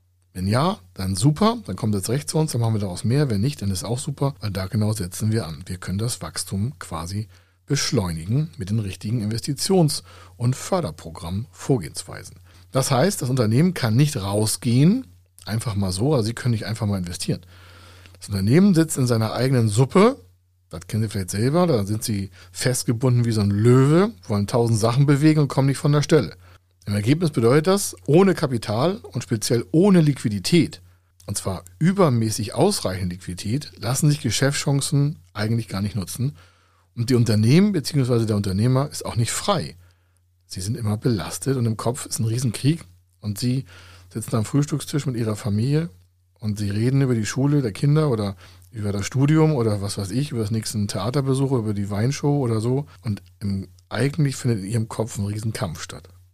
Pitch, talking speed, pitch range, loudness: 115 Hz, 185 wpm, 95-135 Hz, -22 LUFS